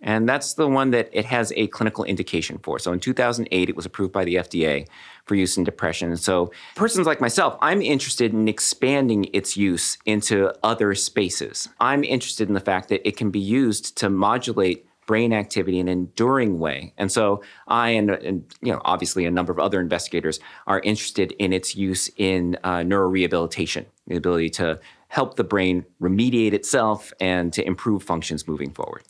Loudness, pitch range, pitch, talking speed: -22 LUFS, 90-110 Hz, 100 Hz, 190 wpm